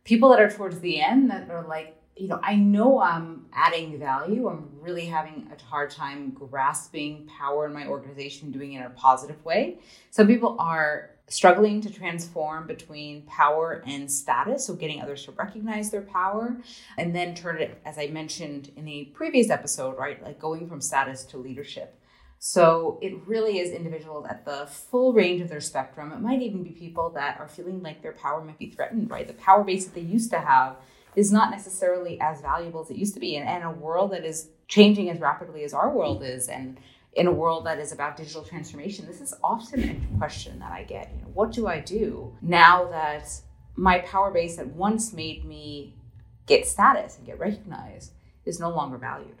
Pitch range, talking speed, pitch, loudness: 150-195 Hz, 205 wpm, 165 Hz, -24 LUFS